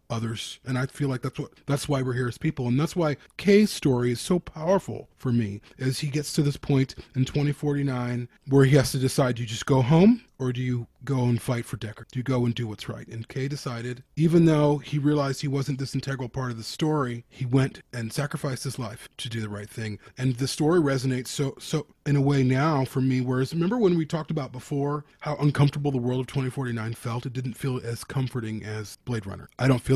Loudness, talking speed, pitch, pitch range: -26 LUFS, 245 wpm, 135 Hz, 125-145 Hz